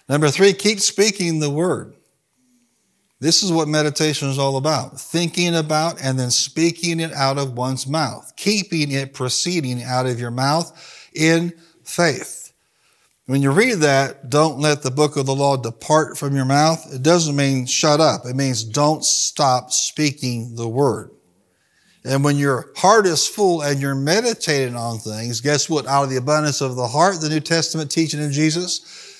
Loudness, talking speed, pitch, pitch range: -18 LUFS, 175 wpm, 150 Hz, 135-165 Hz